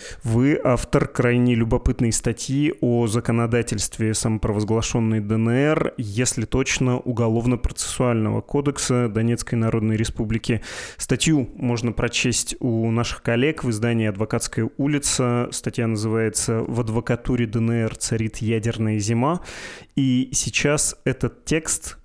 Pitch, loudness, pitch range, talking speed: 120 Hz, -22 LUFS, 115-125 Hz, 105 wpm